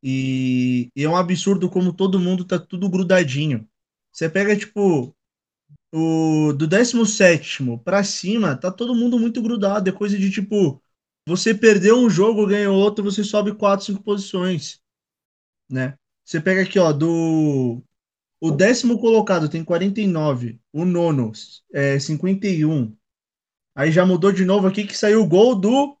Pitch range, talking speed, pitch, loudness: 150-205 Hz, 150 wpm, 185 Hz, -19 LUFS